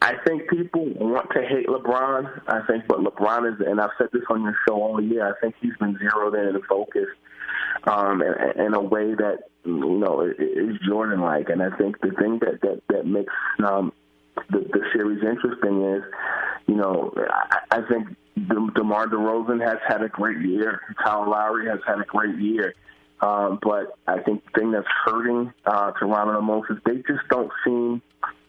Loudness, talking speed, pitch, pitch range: -23 LUFS, 190 wpm, 110 Hz, 105-120 Hz